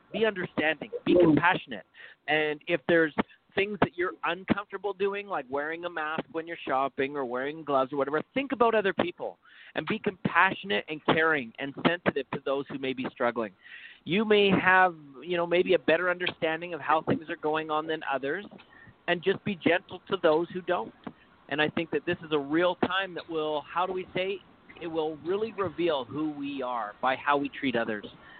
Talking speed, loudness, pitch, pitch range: 195 wpm, -28 LUFS, 165 Hz, 150-190 Hz